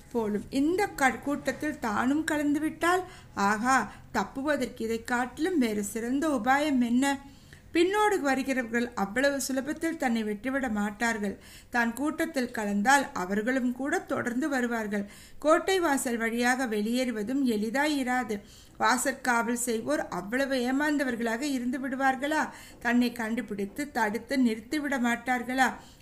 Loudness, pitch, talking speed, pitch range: -28 LUFS, 260 Hz, 105 wpm, 230-285 Hz